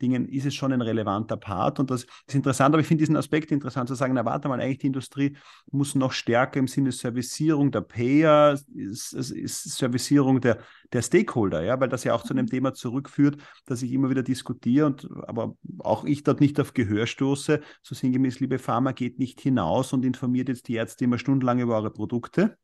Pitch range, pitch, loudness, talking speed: 125-140 Hz, 130 Hz, -25 LUFS, 210 wpm